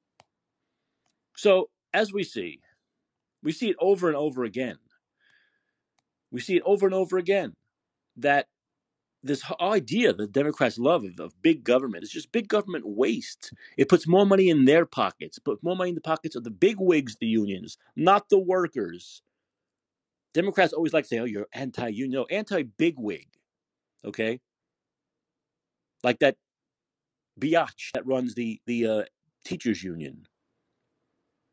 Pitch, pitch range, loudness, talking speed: 155 Hz, 120-190 Hz, -25 LUFS, 150 wpm